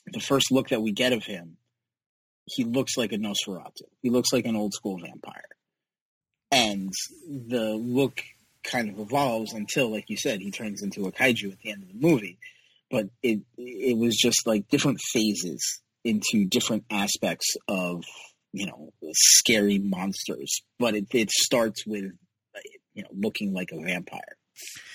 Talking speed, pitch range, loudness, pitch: 165 wpm, 105-130 Hz, -25 LUFS, 115 Hz